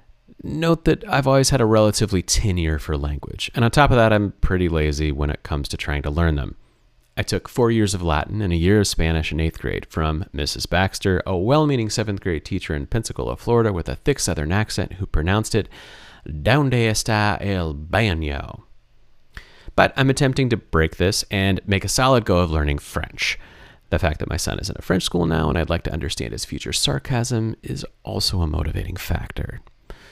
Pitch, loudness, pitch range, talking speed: 95 Hz, -21 LUFS, 80-110 Hz, 205 wpm